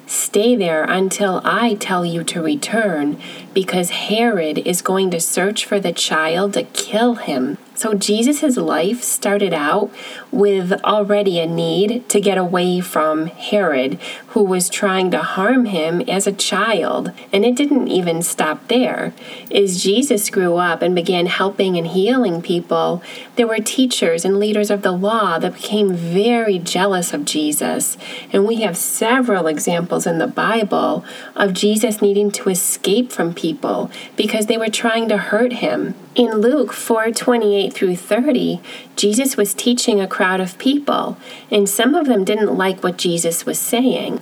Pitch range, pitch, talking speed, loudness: 180-225 Hz, 205 Hz, 160 wpm, -17 LUFS